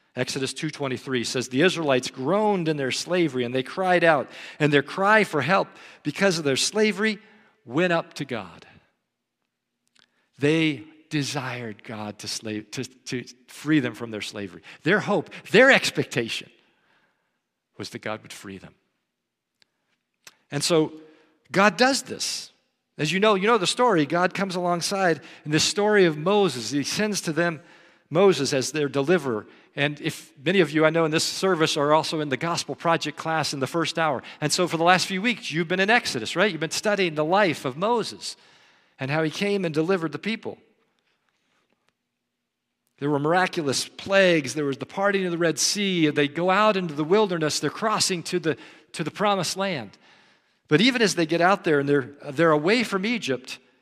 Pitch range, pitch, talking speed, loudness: 140-185 Hz, 160 Hz, 180 wpm, -23 LUFS